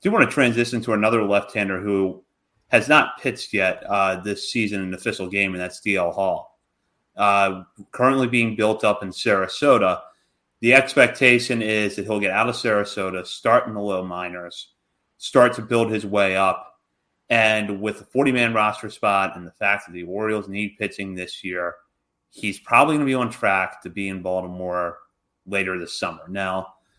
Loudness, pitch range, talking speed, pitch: -21 LUFS, 95-110 Hz, 180 wpm, 100 Hz